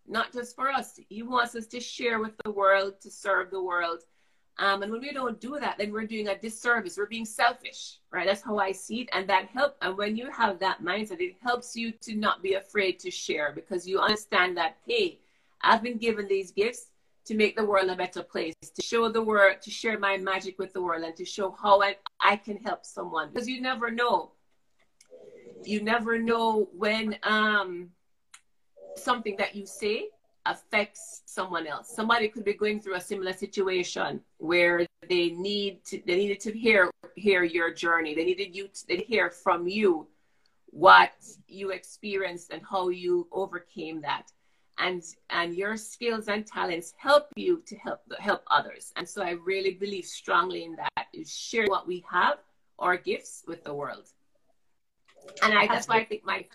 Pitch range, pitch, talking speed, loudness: 190-230 Hz, 205 Hz, 195 wpm, -28 LUFS